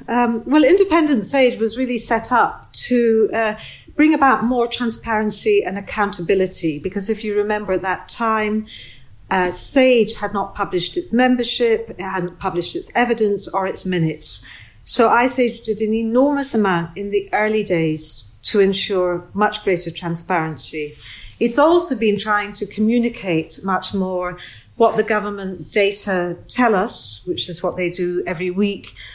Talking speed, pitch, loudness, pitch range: 155 wpm, 205 Hz, -18 LUFS, 180-230 Hz